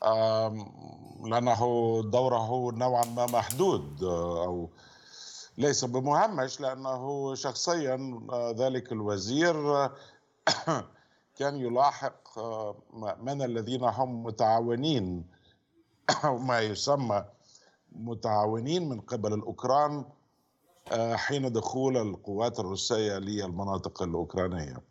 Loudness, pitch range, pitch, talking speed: -30 LUFS, 105-130 Hz, 120 Hz, 75 wpm